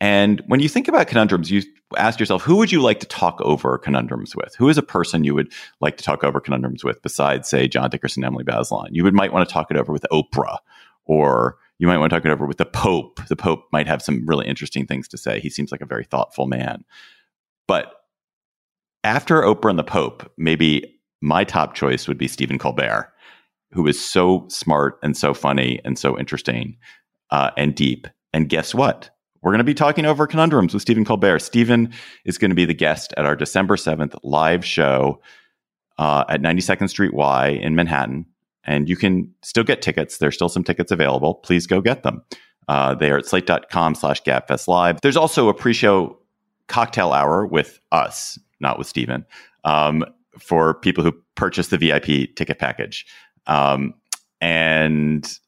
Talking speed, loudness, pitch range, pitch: 195 wpm, -19 LUFS, 70-95 Hz, 80 Hz